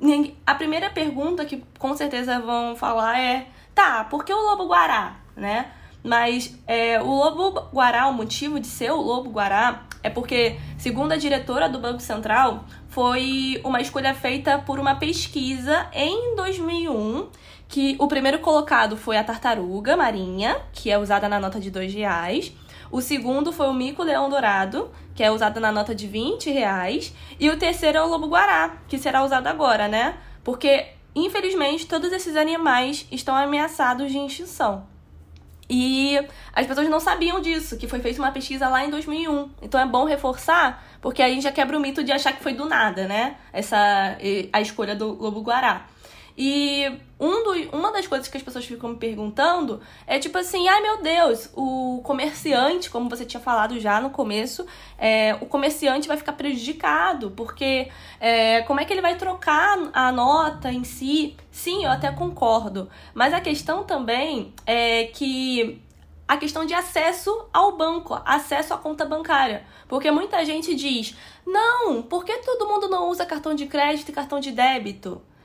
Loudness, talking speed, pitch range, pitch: -22 LUFS, 170 wpm, 235-310 Hz, 275 Hz